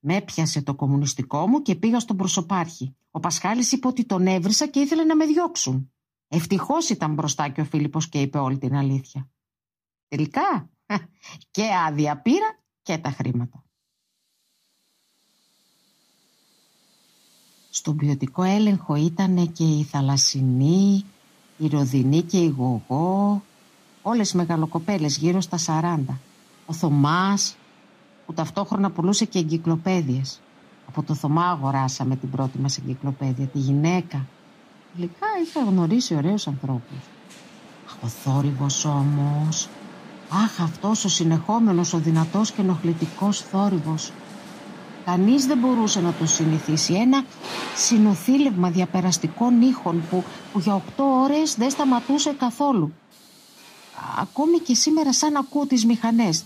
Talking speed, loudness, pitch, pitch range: 125 wpm, -22 LUFS, 175 Hz, 150-215 Hz